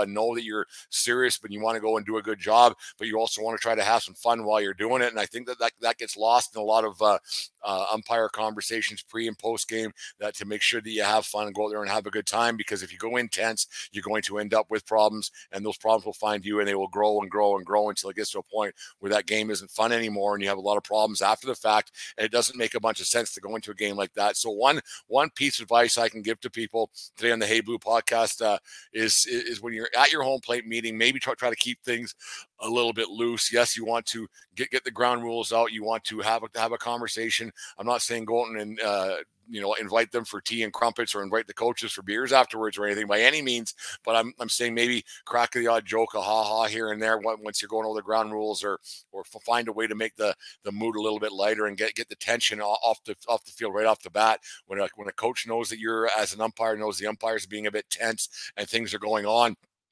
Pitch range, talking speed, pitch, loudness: 105-115 Hz, 285 wpm, 110 Hz, -26 LUFS